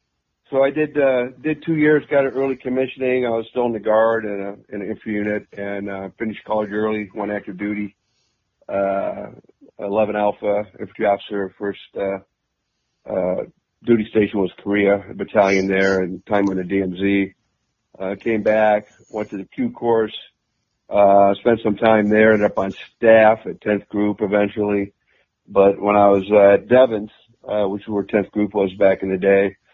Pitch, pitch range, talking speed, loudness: 105 Hz, 100-115 Hz, 180 wpm, -19 LUFS